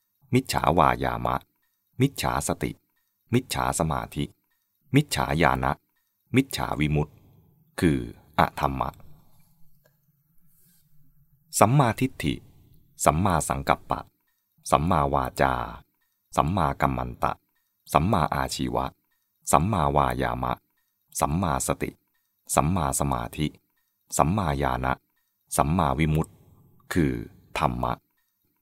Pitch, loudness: 75 Hz, -26 LUFS